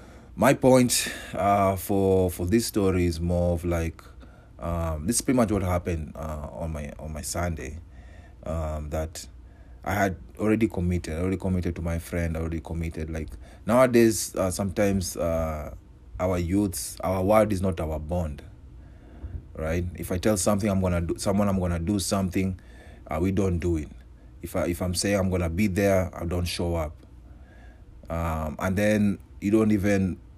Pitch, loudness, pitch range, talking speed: 90 Hz, -26 LUFS, 80-100 Hz, 170 wpm